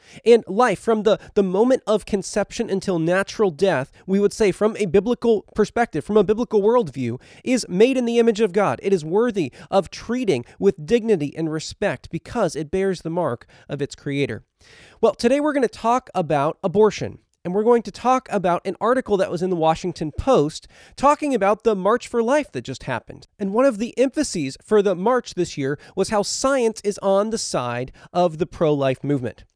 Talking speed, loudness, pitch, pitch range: 200 wpm, -21 LUFS, 200 Hz, 165-230 Hz